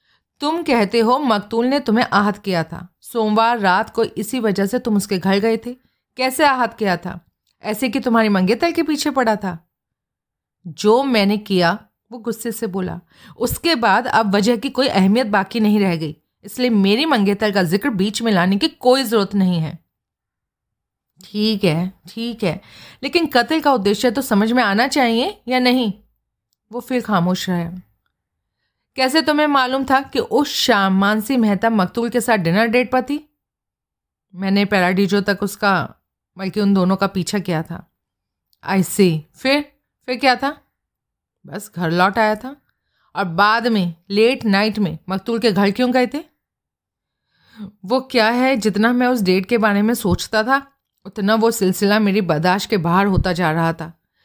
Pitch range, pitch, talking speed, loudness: 190-250 Hz, 215 Hz, 170 wpm, -18 LUFS